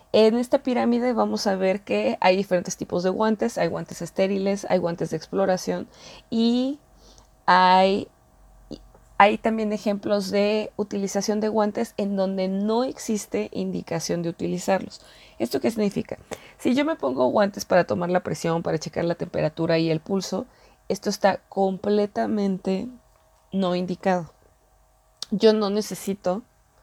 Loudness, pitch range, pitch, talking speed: -24 LUFS, 180-215 Hz, 195 Hz, 140 wpm